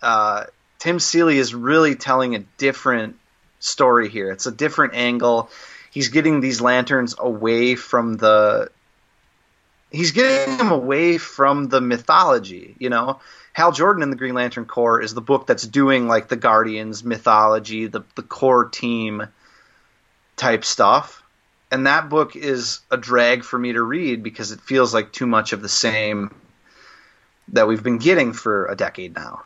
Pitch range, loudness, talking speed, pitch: 115-140 Hz, -18 LUFS, 160 wpm, 120 Hz